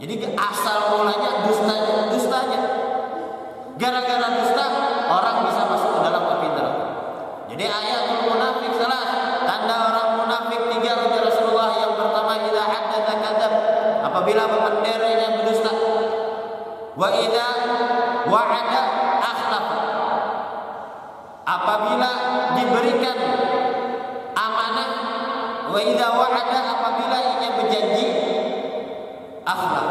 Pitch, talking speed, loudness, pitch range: 225 Hz, 90 wpm, -21 LUFS, 220-245 Hz